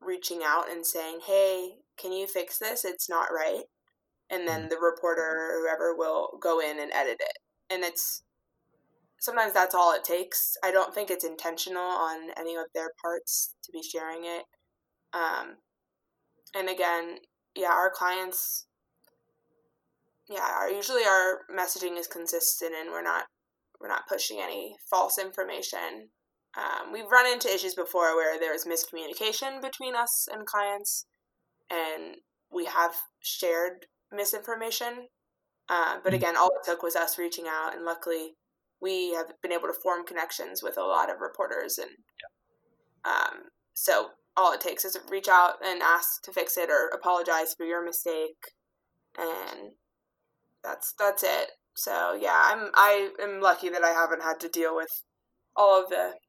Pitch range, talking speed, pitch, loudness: 165-205 Hz, 160 wpm, 180 Hz, -28 LUFS